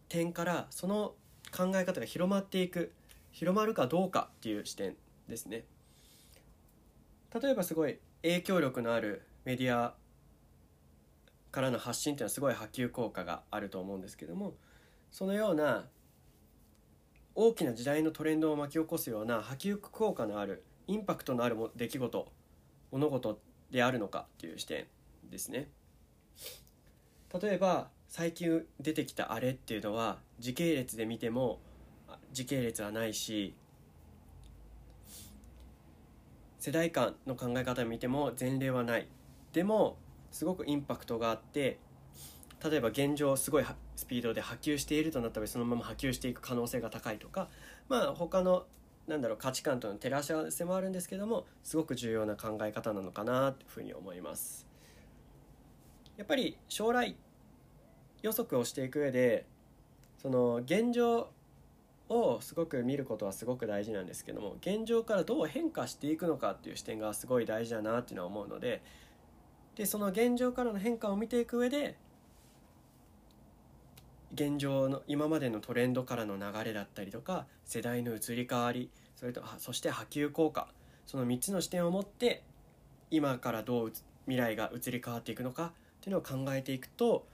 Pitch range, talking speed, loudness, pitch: 115-170 Hz, 325 characters per minute, -35 LUFS, 130 Hz